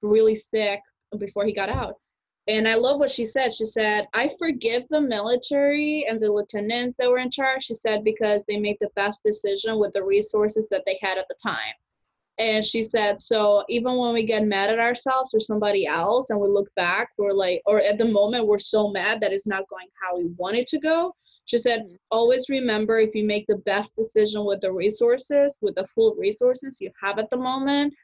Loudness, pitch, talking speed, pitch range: -23 LUFS, 220 Hz, 215 wpm, 205-250 Hz